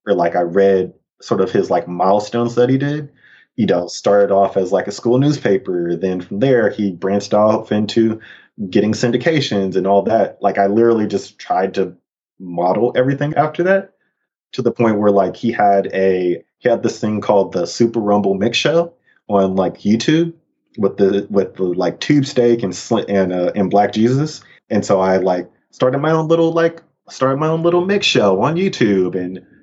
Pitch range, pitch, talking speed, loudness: 95-135 Hz, 105 Hz, 195 wpm, -16 LUFS